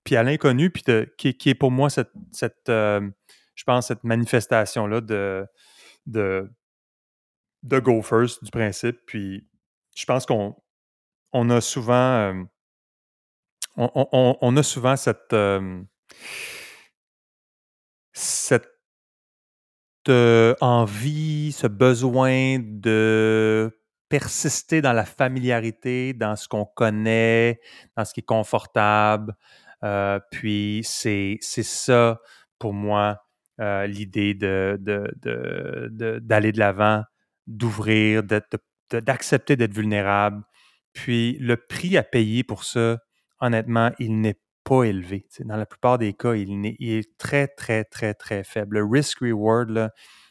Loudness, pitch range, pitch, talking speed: -22 LUFS, 105-125 Hz, 115 Hz, 135 wpm